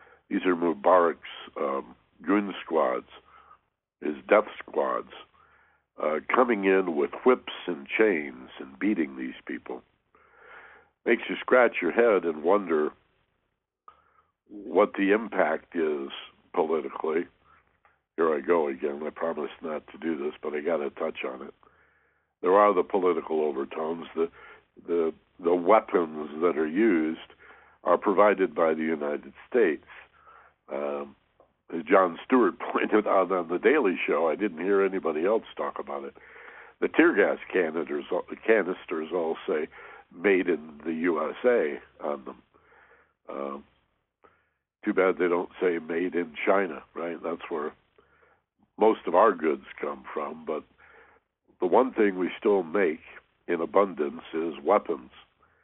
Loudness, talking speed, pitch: -27 LUFS, 135 wpm, 95 Hz